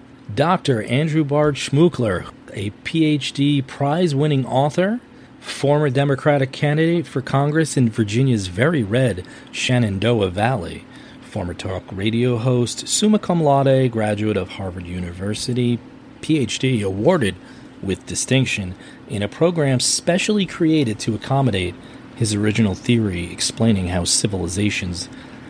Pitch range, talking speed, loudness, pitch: 105-145 Hz, 115 wpm, -19 LUFS, 125 Hz